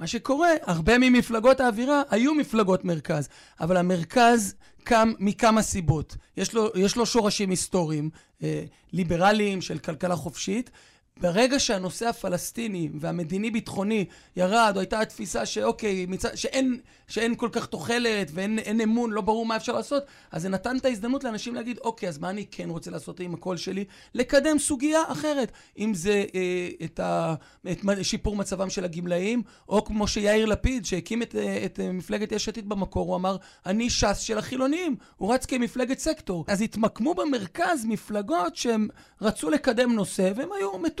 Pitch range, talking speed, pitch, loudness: 185-240 Hz, 160 wpm, 215 Hz, -26 LUFS